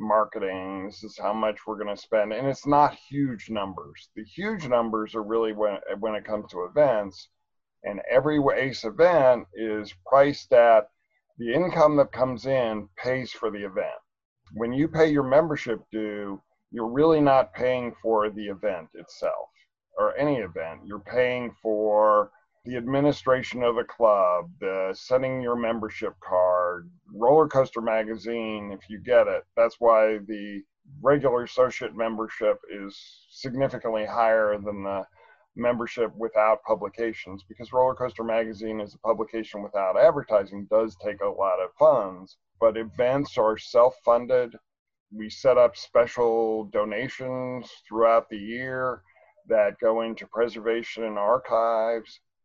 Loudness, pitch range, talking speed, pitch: -25 LUFS, 105-125 Hz, 145 wpm, 115 Hz